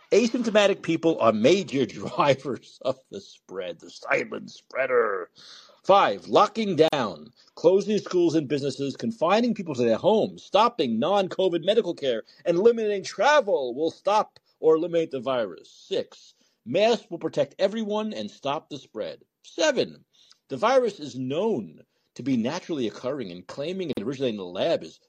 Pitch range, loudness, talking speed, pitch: 160-235 Hz, -25 LUFS, 150 wpm, 195 Hz